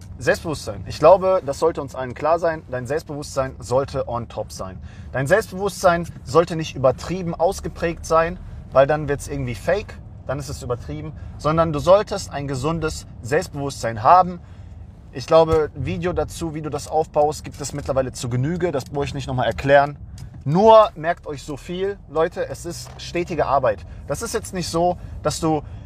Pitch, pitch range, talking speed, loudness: 145 Hz, 130-165 Hz, 175 wpm, -21 LUFS